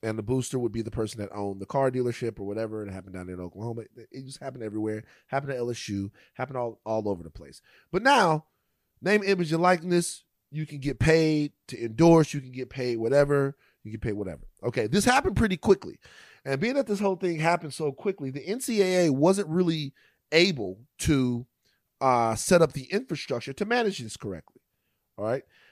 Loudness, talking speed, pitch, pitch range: -27 LUFS, 195 wpm, 135 Hz, 110-165 Hz